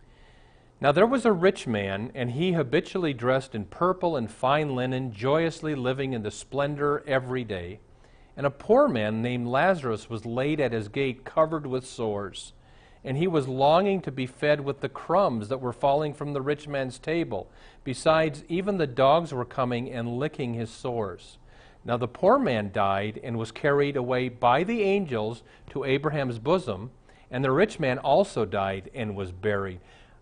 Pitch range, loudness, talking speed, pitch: 115-150 Hz, -26 LUFS, 175 wpm, 130 Hz